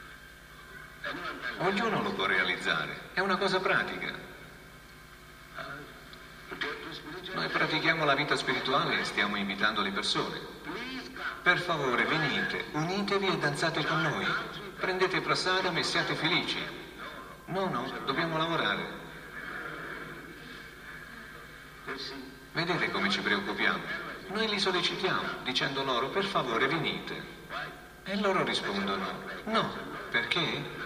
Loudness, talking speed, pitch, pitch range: -30 LUFS, 100 wpm, 185 Hz, 155-195 Hz